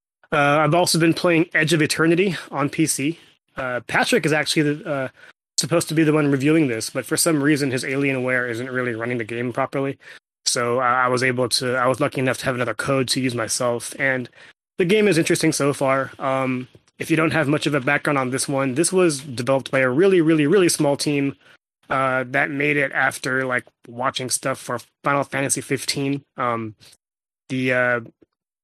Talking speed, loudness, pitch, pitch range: 200 wpm, -20 LUFS, 140 Hz, 130-155 Hz